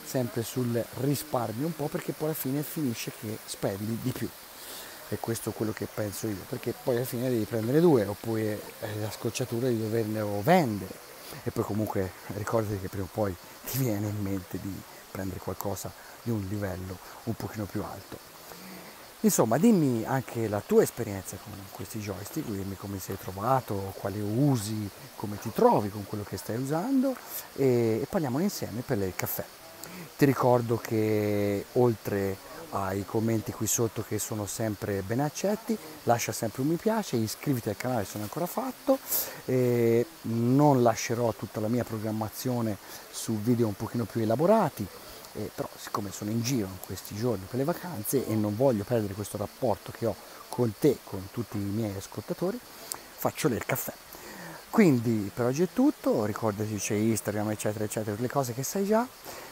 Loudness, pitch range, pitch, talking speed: -29 LUFS, 105-130 Hz, 115 Hz, 170 wpm